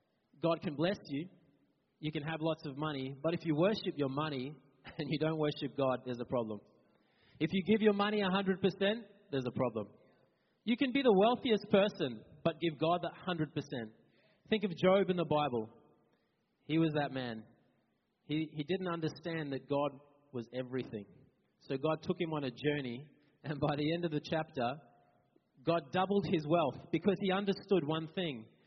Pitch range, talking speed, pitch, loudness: 135-180 Hz, 180 wpm, 155 Hz, -35 LUFS